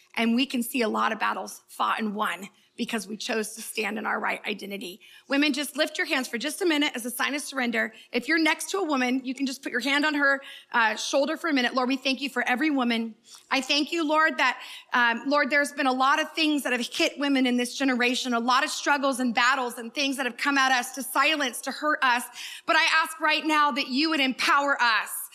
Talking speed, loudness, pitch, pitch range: 255 wpm, -25 LUFS, 270 Hz, 245-295 Hz